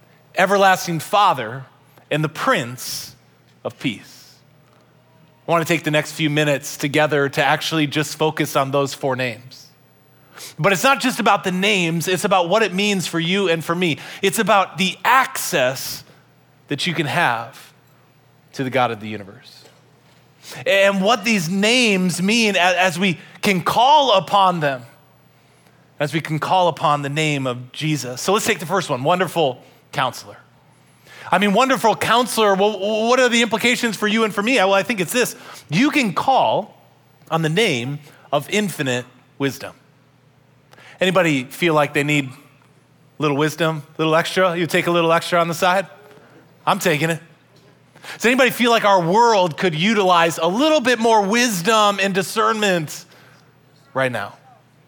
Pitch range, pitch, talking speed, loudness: 145-195 Hz, 165 Hz, 165 wpm, -18 LUFS